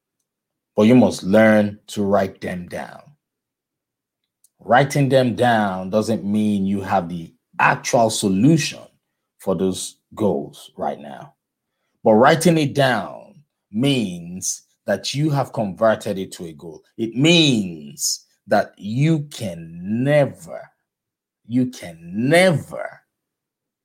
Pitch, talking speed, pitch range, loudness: 115 Hz, 115 wpm, 100-145 Hz, -19 LUFS